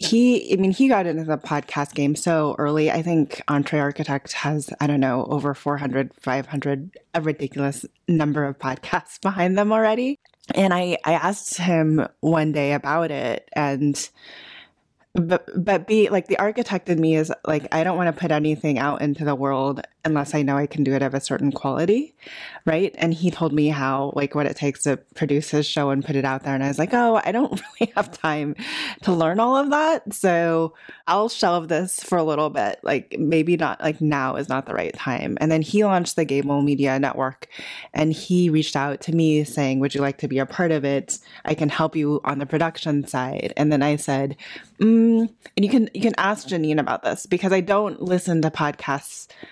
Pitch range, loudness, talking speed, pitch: 145-180 Hz, -22 LUFS, 210 wpm, 155 Hz